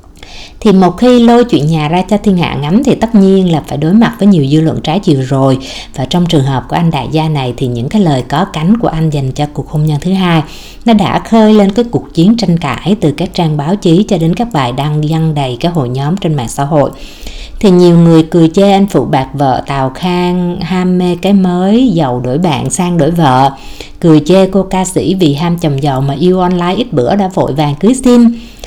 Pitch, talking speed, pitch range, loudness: 170 Hz, 245 wpm, 145-190 Hz, -10 LUFS